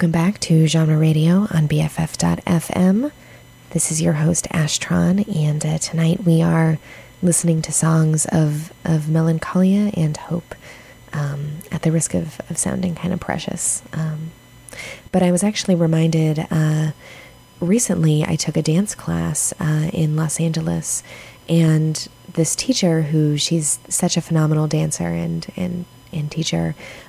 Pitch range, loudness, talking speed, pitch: 155-170 Hz, -19 LUFS, 145 wpm, 160 Hz